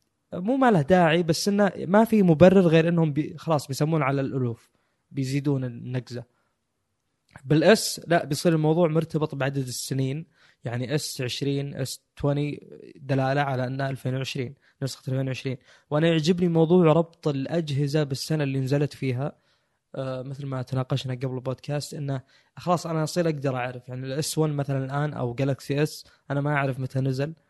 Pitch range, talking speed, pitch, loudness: 130-160 Hz, 150 wpm, 140 Hz, -25 LUFS